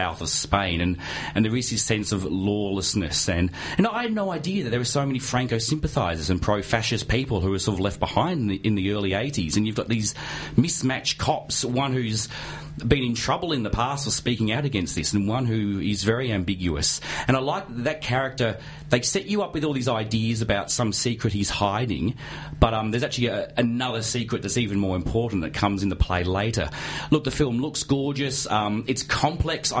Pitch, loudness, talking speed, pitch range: 115 Hz, -24 LUFS, 215 wpm, 100-130 Hz